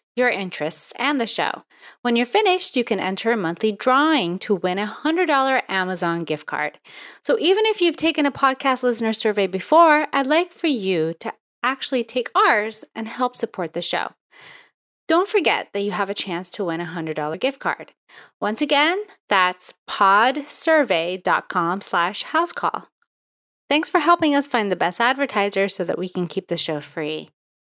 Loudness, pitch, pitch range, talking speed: -21 LUFS, 230 Hz, 185-295 Hz, 170 wpm